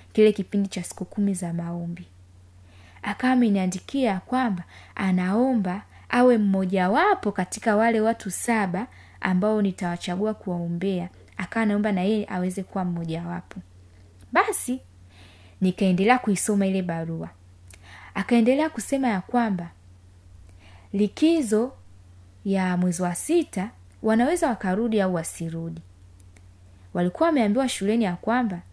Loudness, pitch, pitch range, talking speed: -24 LUFS, 185 Hz, 160-215 Hz, 110 wpm